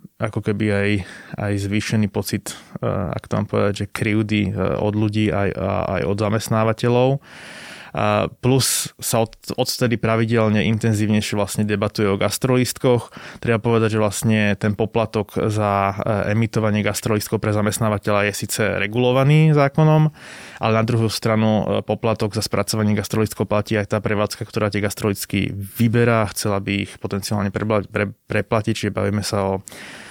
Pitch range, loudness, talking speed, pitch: 105-115 Hz, -20 LUFS, 135 wpm, 105 Hz